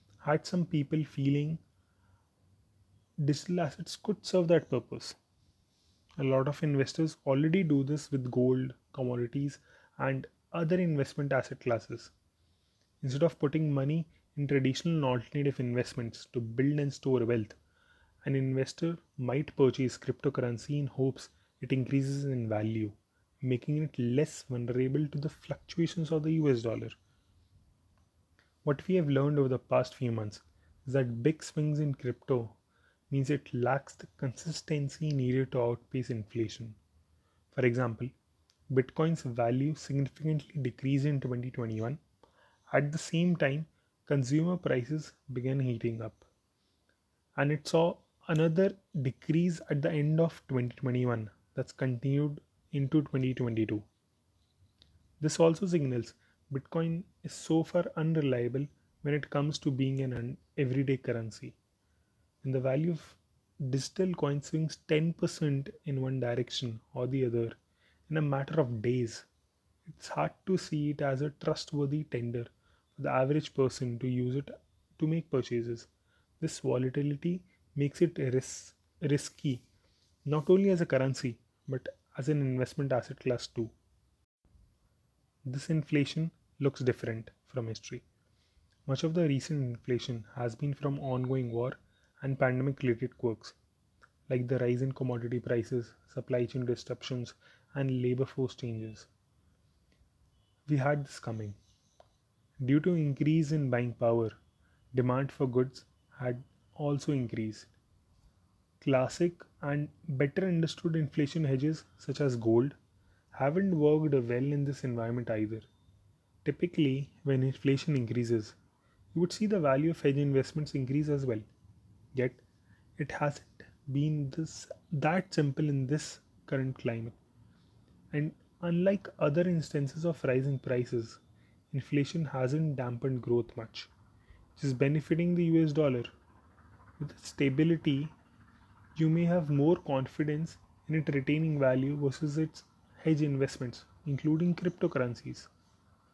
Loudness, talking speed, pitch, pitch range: -32 LUFS, 130 wpm, 135 Hz, 115-150 Hz